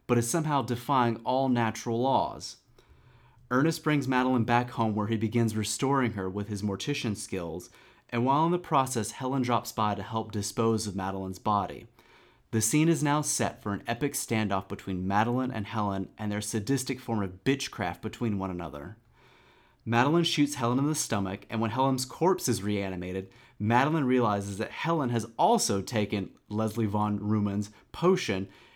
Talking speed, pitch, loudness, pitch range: 165 wpm, 115 Hz, -29 LUFS, 105-130 Hz